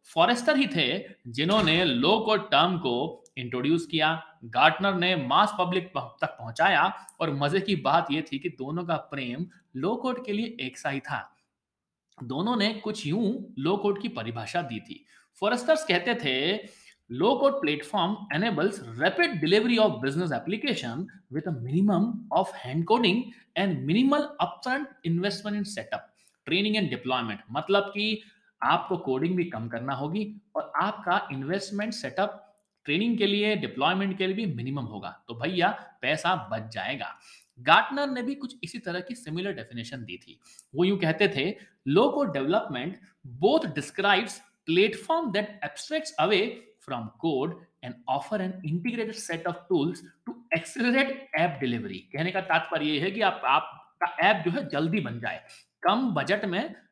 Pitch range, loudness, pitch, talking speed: 155-215 Hz, -27 LUFS, 190 Hz, 145 wpm